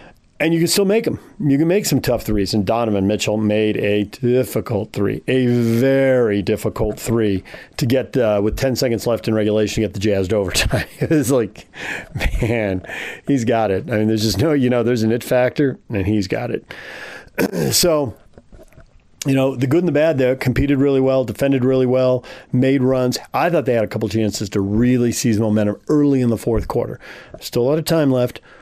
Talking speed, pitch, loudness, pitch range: 205 wpm, 120 Hz, -18 LUFS, 110-135 Hz